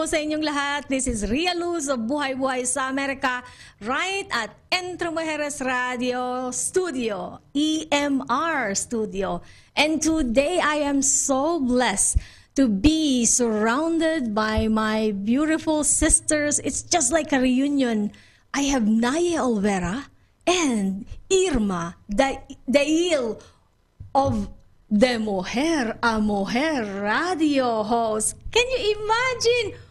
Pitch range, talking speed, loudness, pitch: 230-315 Hz, 110 wpm, -22 LUFS, 270 Hz